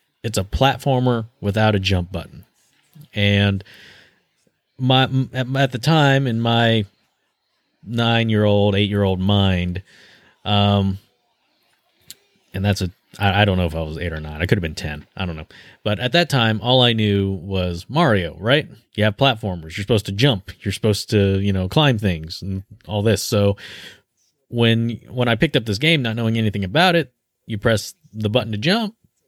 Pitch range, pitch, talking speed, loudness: 95-125 Hz, 105 Hz, 175 wpm, -19 LUFS